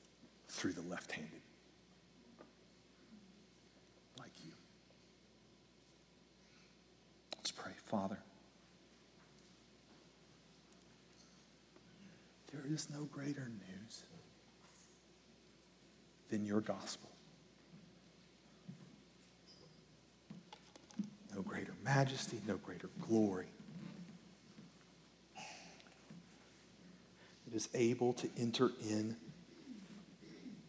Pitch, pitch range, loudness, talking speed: 180 Hz, 125-190 Hz, -43 LUFS, 55 wpm